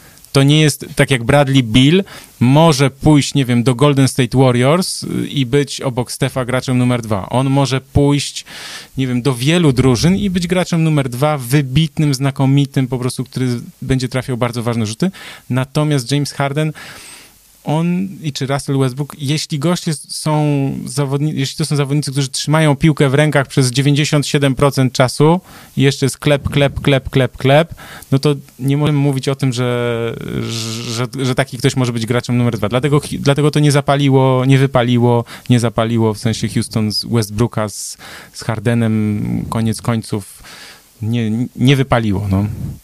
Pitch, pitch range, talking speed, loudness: 135 Hz, 125-145 Hz, 165 wpm, -15 LUFS